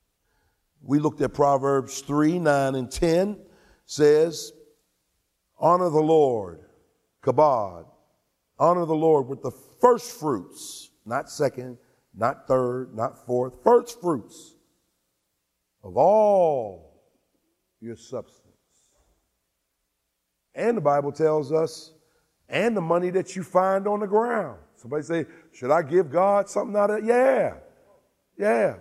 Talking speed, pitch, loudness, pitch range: 120 wpm, 155 Hz, -23 LUFS, 125-185 Hz